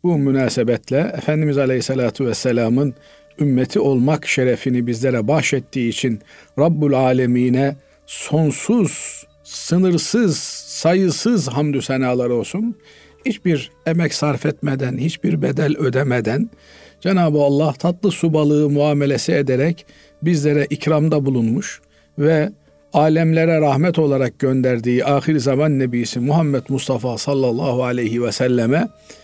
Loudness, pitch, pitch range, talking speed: -18 LUFS, 145 Hz, 130-160 Hz, 105 wpm